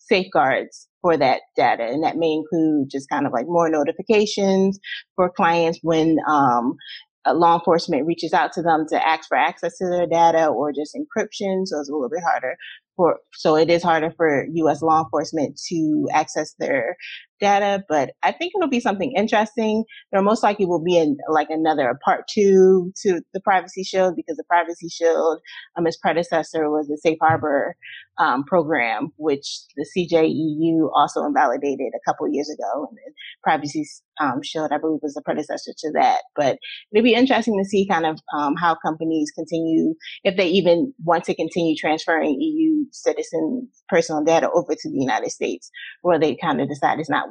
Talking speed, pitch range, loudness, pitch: 185 wpm, 160-210 Hz, -20 LUFS, 170 Hz